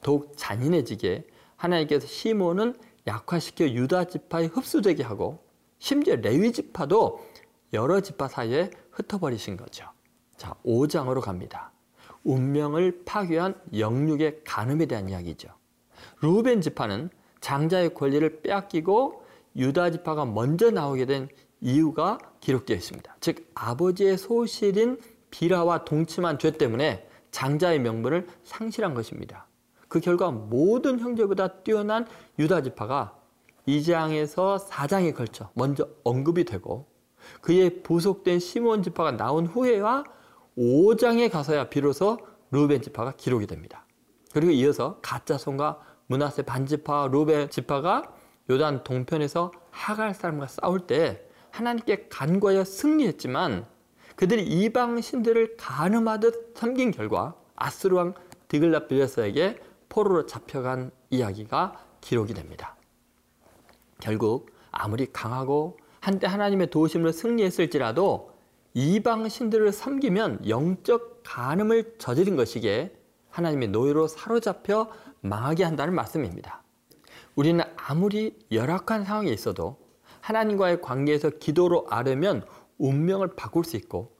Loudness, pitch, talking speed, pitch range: -26 LUFS, 170 Hz, 290 characters per minute, 140-210 Hz